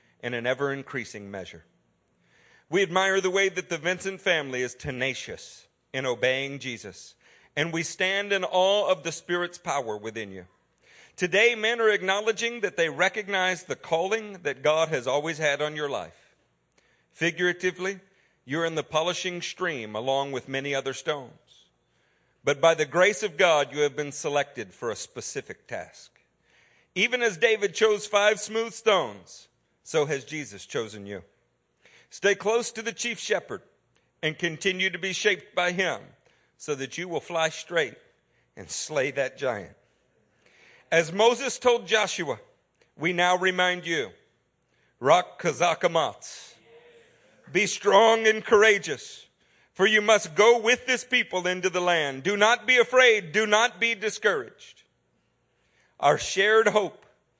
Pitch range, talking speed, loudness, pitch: 145-210 Hz, 145 wpm, -25 LUFS, 180 Hz